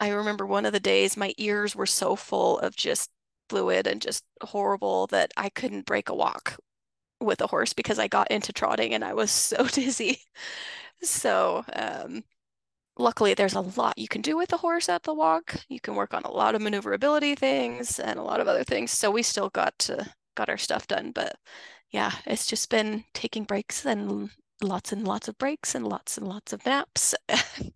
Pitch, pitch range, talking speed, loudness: 220 Hz, 195-285 Hz, 205 wpm, -27 LUFS